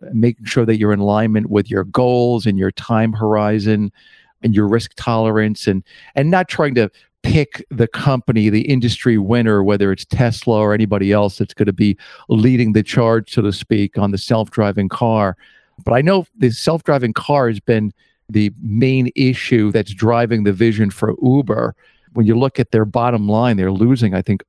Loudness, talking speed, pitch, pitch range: -16 LUFS, 185 wpm, 110 Hz, 105-120 Hz